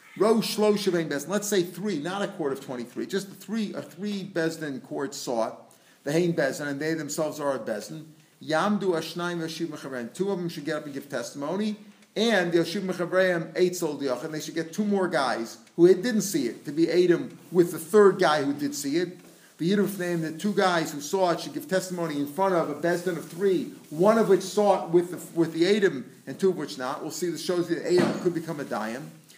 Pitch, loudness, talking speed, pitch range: 175 Hz, -26 LUFS, 220 wpm, 155-195 Hz